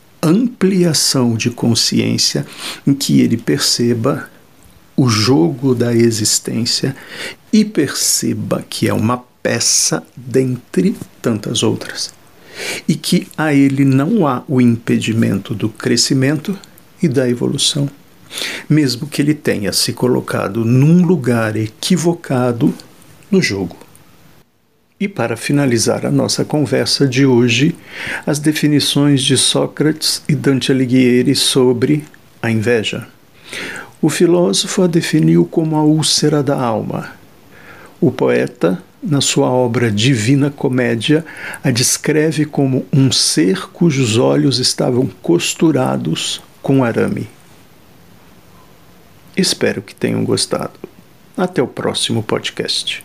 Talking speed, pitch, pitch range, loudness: 110 wpm, 140 Hz, 120-155 Hz, -15 LUFS